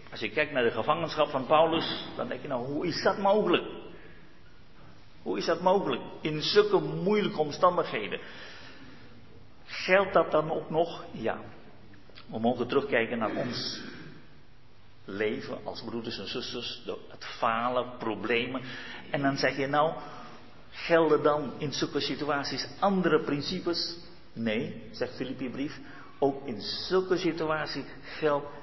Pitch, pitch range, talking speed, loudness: 150 Hz, 125-170 Hz, 130 wpm, -29 LUFS